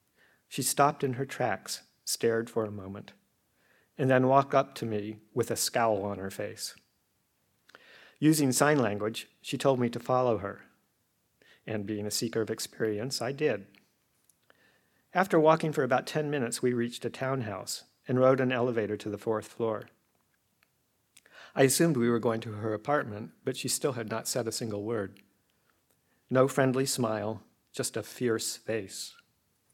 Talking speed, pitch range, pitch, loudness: 160 wpm, 110-135 Hz, 120 Hz, -30 LUFS